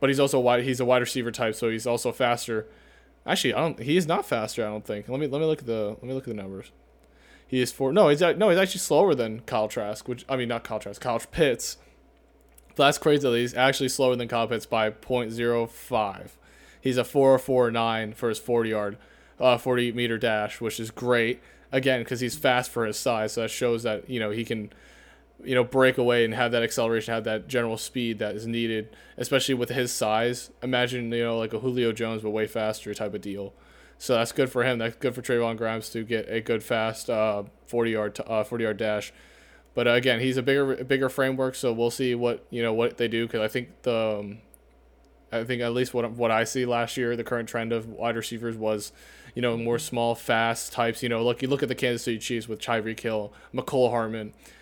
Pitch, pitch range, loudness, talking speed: 115 Hz, 110-125 Hz, -26 LUFS, 230 wpm